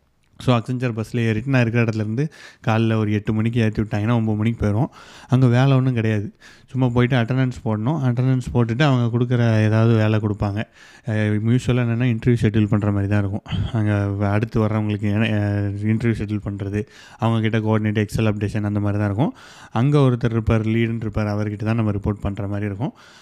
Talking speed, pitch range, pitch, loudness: 170 wpm, 105-120 Hz, 110 Hz, -21 LUFS